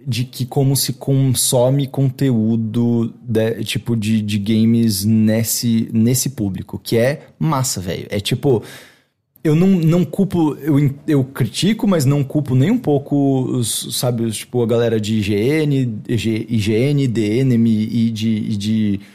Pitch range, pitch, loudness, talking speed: 110-140 Hz, 120 Hz, -17 LUFS, 145 wpm